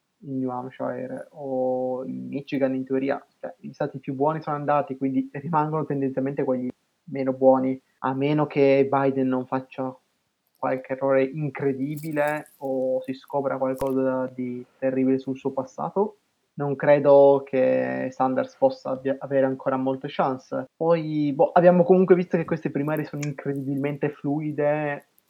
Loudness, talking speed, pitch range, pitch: -24 LUFS, 140 wpm, 130-150 Hz, 135 Hz